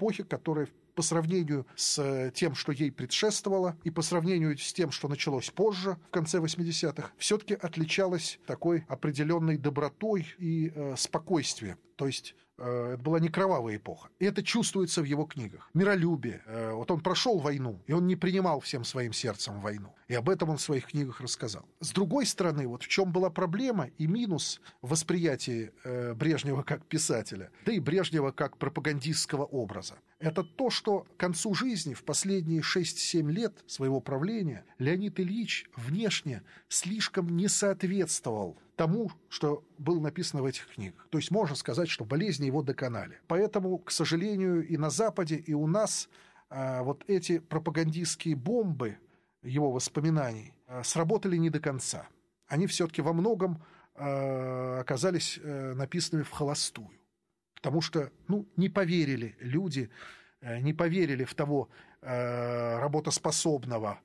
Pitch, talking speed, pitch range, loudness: 160 Hz, 150 wpm, 135-180 Hz, -31 LUFS